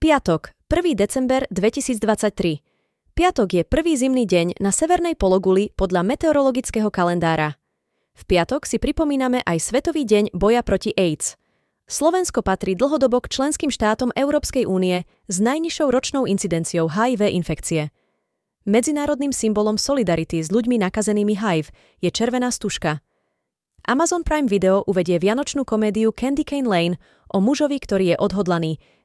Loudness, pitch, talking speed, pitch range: -20 LUFS, 215 Hz, 130 wpm, 185-270 Hz